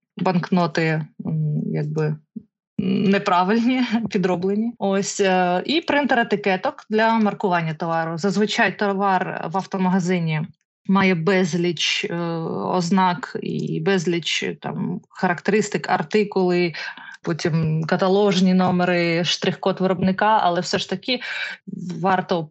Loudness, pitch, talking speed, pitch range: -21 LUFS, 190 Hz, 90 wpm, 175-205 Hz